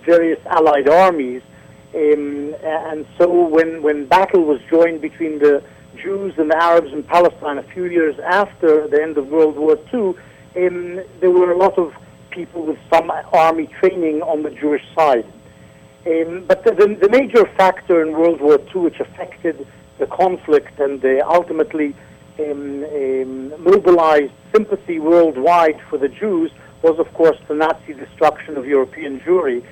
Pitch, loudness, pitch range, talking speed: 165 Hz, -16 LUFS, 150-185 Hz, 160 wpm